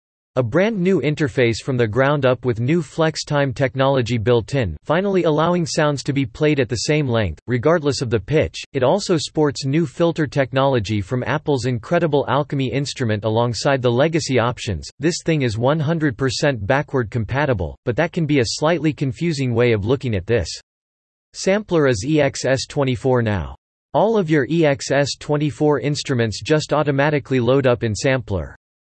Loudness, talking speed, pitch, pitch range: -19 LUFS, 160 wpm, 135 Hz, 120-150 Hz